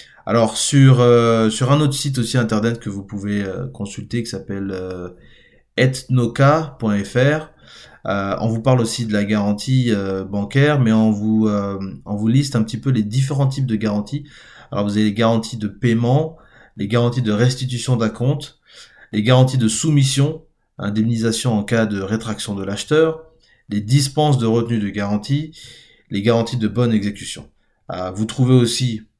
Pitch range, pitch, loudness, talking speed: 105-130 Hz, 115 Hz, -18 LUFS, 170 wpm